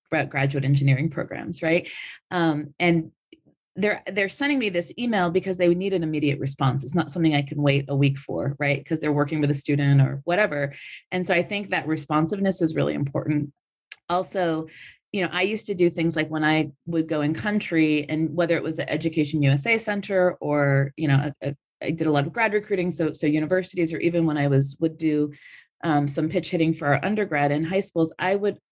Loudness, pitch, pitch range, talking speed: -24 LUFS, 160 Hz, 145-180 Hz, 215 wpm